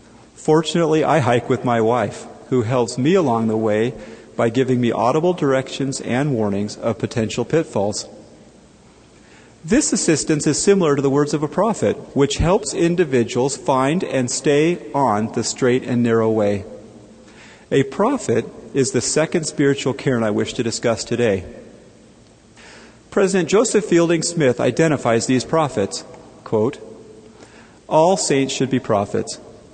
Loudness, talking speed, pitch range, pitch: -19 LUFS, 140 wpm, 115-155 Hz, 130 Hz